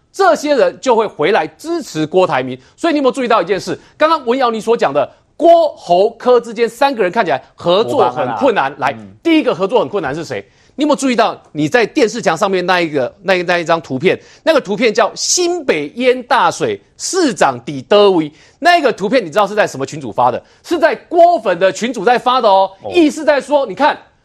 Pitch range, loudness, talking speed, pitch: 185-310 Hz, -14 LUFS, 320 characters per minute, 240 Hz